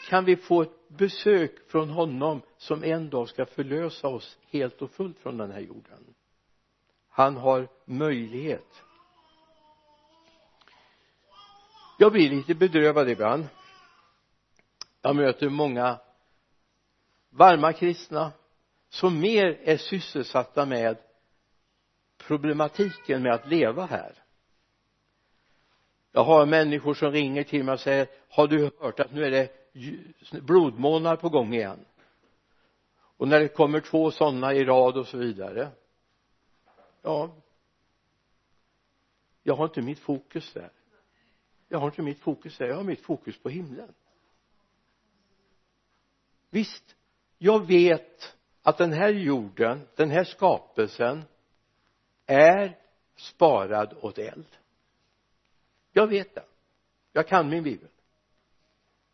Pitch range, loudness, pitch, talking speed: 135-175 Hz, -25 LUFS, 150 Hz, 115 wpm